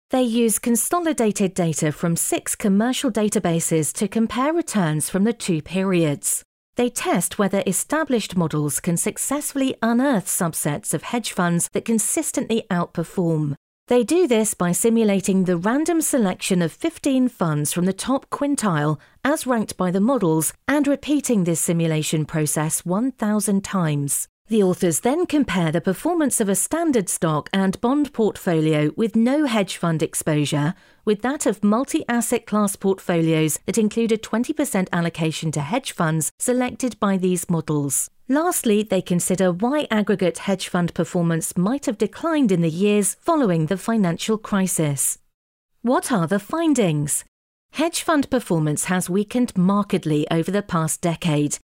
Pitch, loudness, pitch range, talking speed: 200 Hz, -21 LUFS, 170-245 Hz, 145 wpm